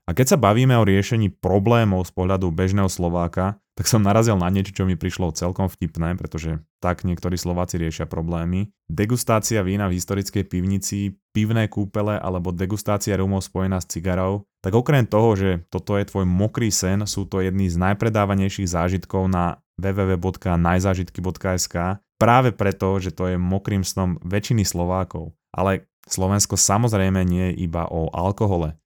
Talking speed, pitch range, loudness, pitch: 155 wpm, 90-100 Hz, -21 LUFS, 95 Hz